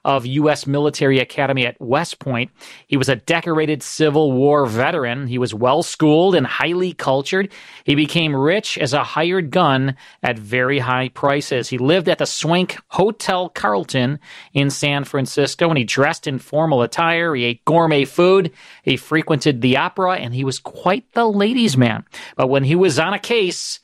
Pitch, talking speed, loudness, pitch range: 145 Hz, 175 wpm, -18 LUFS, 135-170 Hz